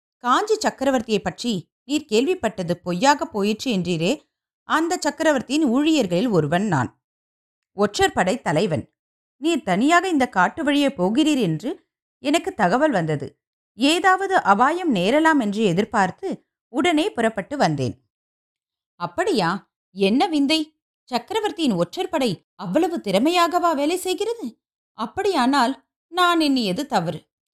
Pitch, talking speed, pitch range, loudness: 265 Hz, 105 wpm, 195-315 Hz, -21 LUFS